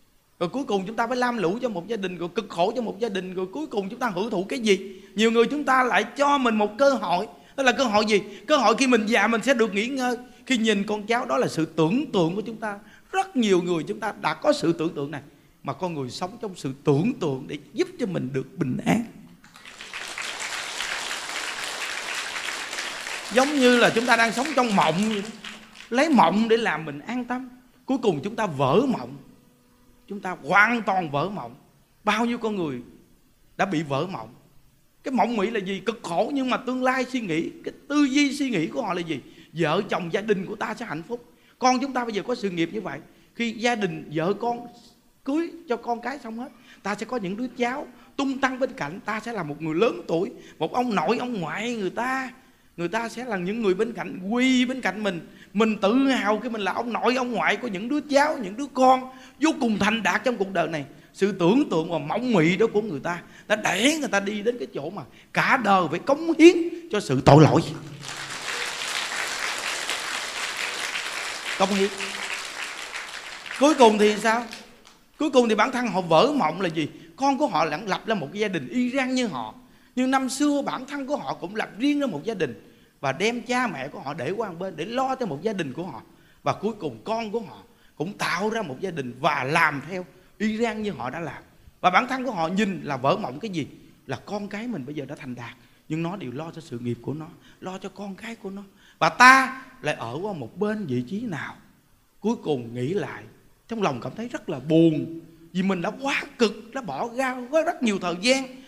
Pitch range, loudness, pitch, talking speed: 175-250 Hz, -24 LUFS, 215 Hz, 230 wpm